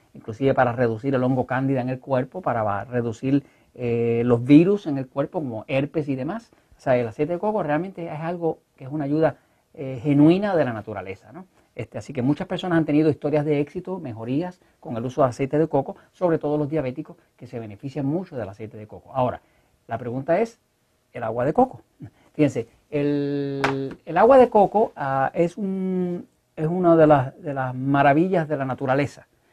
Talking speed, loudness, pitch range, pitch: 195 wpm, -22 LUFS, 130-165 Hz, 145 Hz